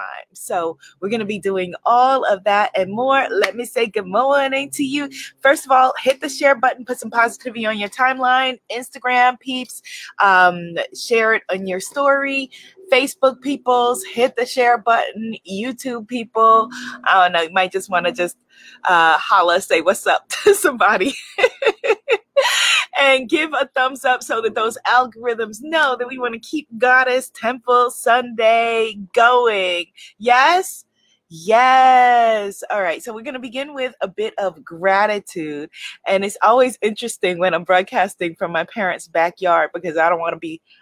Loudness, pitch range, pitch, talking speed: -17 LUFS, 200-265 Hz, 240 Hz, 165 wpm